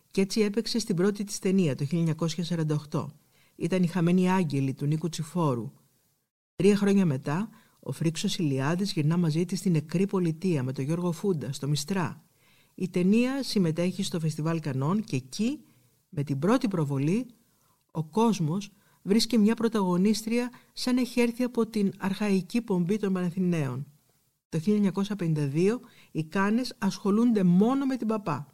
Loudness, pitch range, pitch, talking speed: -27 LUFS, 155-210 Hz, 185 Hz, 145 wpm